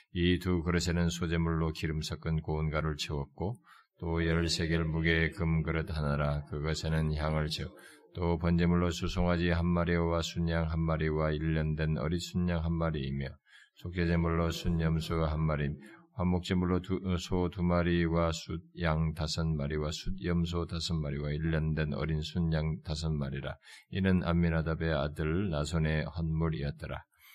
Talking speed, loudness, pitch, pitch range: 315 characters per minute, -32 LUFS, 80 Hz, 80-85 Hz